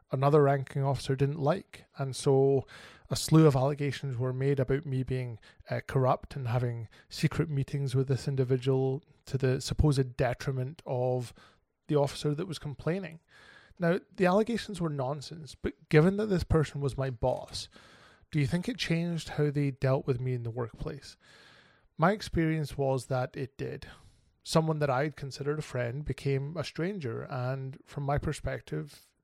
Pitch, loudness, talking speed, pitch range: 140 Hz, -30 LUFS, 165 wpm, 130-155 Hz